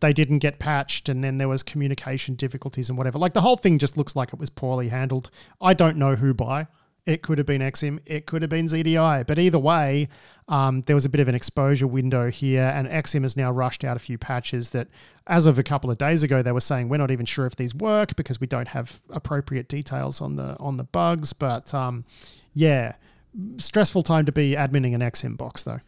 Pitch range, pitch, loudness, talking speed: 130-155 Hz, 140 Hz, -23 LUFS, 235 wpm